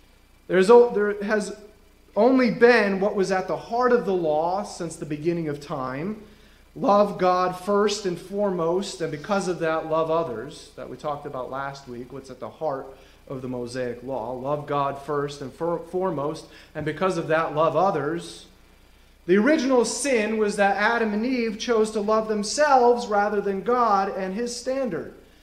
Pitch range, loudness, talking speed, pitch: 150-215 Hz, -23 LUFS, 170 wpm, 185 Hz